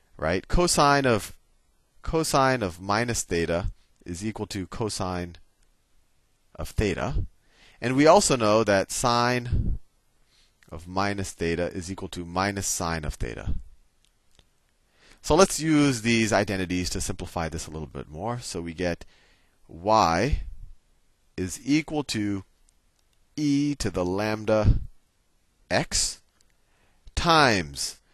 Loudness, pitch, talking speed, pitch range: -25 LUFS, 100 Hz, 115 wpm, 85-120 Hz